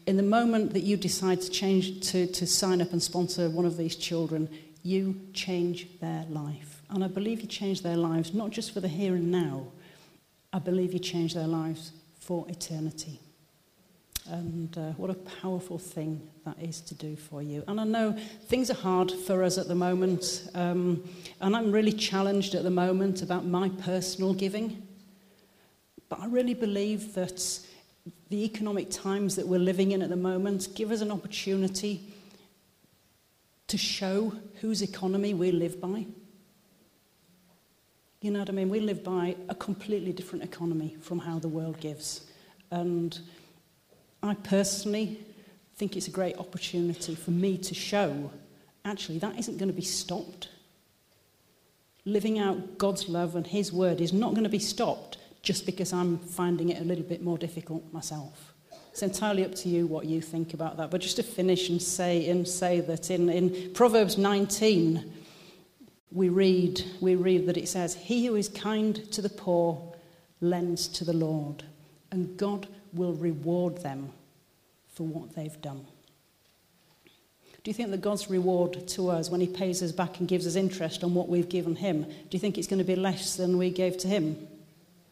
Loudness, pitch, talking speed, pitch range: -30 LUFS, 180 Hz, 175 wpm, 170-195 Hz